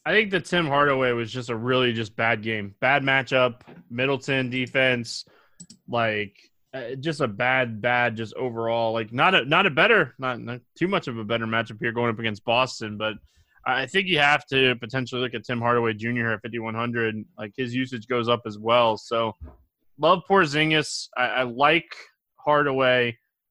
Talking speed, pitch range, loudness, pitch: 180 wpm, 115-135 Hz, -23 LUFS, 125 Hz